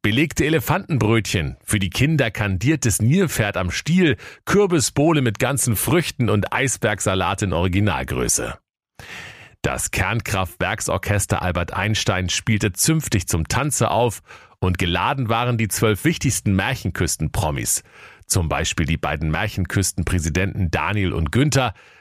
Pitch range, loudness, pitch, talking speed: 95-135 Hz, -20 LUFS, 110 Hz, 110 wpm